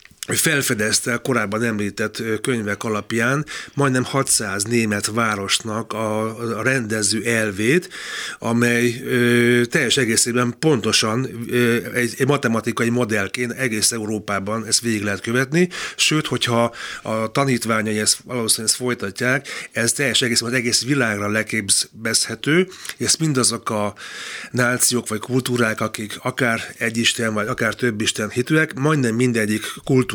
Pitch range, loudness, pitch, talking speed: 110-125 Hz, -19 LUFS, 115 Hz, 110 wpm